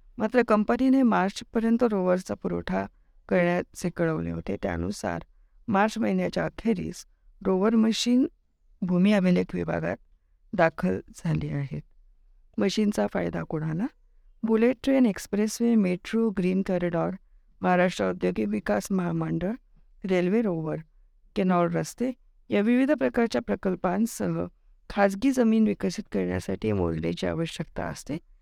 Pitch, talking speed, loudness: 180 Hz, 105 wpm, -26 LUFS